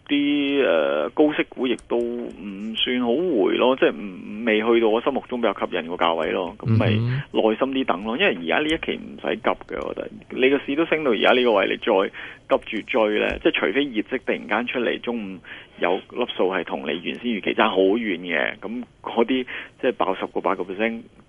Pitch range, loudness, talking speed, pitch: 110-145 Hz, -22 LUFS, 315 characters per minute, 120 Hz